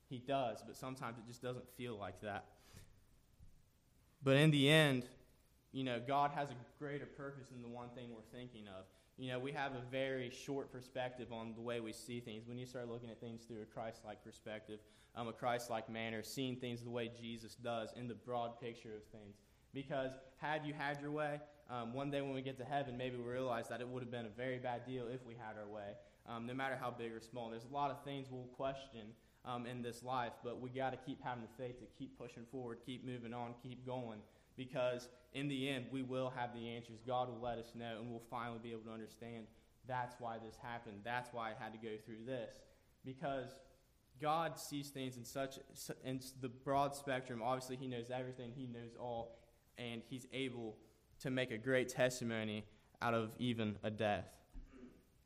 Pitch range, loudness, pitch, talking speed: 115-130 Hz, -44 LUFS, 125 Hz, 215 wpm